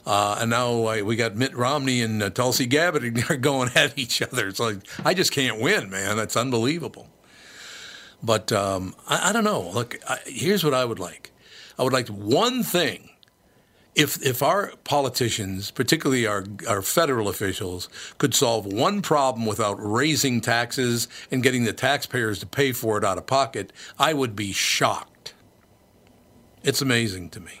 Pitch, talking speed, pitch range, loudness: 120 Hz, 170 wpm, 105-135 Hz, -23 LUFS